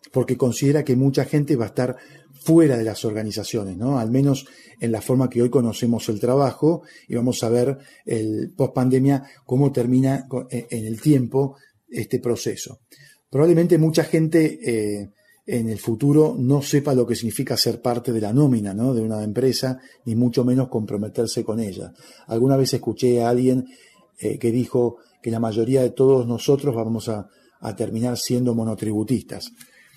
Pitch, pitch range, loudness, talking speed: 125 Hz, 115-135 Hz, -21 LUFS, 170 wpm